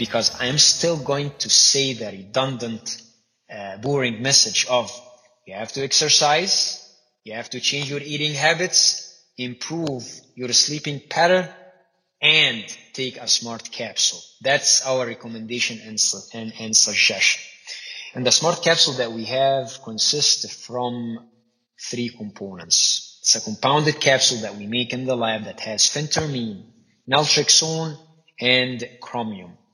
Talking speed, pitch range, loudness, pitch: 135 wpm, 115-145 Hz, -19 LUFS, 125 Hz